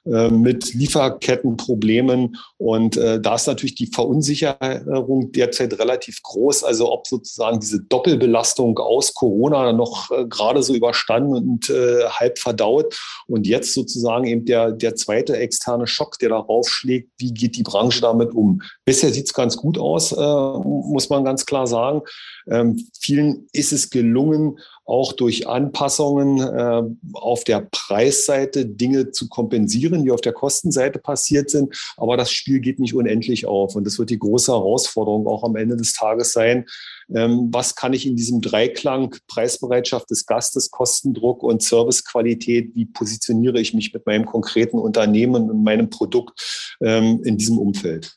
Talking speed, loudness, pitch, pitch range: 155 wpm, -19 LUFS, 120 Hz, 115-135 Hz